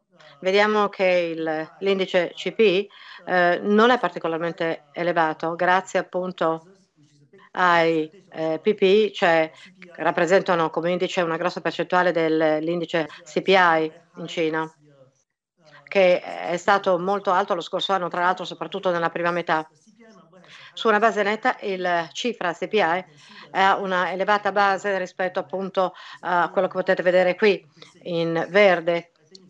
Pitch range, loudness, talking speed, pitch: 165-195 Hz, -22 LUFS, 130 wpm, 180 Hz